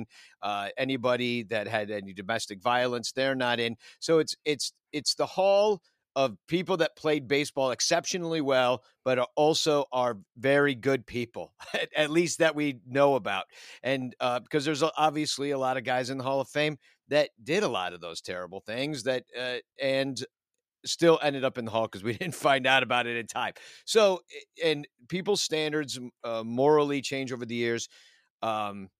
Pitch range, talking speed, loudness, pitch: 120-150 Hz, 180 wpm, -28 LUFS, 135 Hz